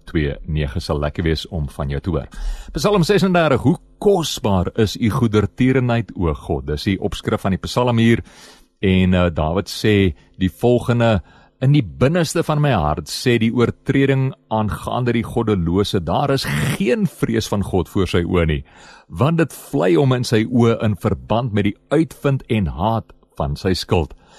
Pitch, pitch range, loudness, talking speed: 110 Hz, 90-130 Hz, -19 LUFS, 175 wpm